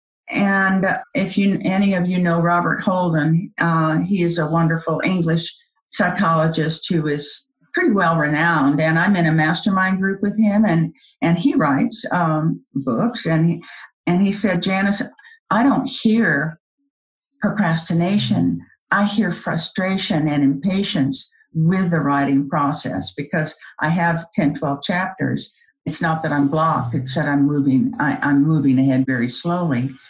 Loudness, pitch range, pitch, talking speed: -19 LUFS, 155-195 Hz, 170 Hz, 150 wpm